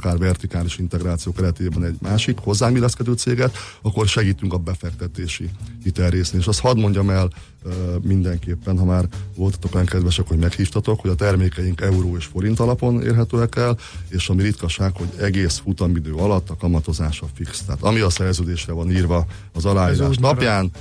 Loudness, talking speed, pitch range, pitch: -20 LUFS, 155 wpm, 90-105 Hz, 95 Hz